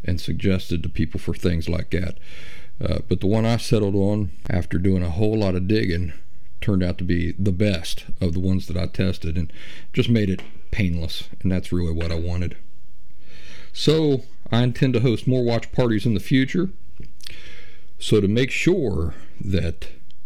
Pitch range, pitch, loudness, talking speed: 85-110 Hz, 95 Hz, -23 LUFS, 180 wpm